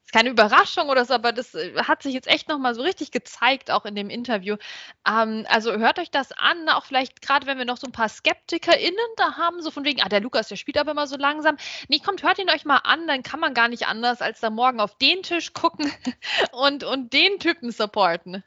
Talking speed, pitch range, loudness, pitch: 245 wpm, 235-320 Hz, -22 LUFS, 280 Hz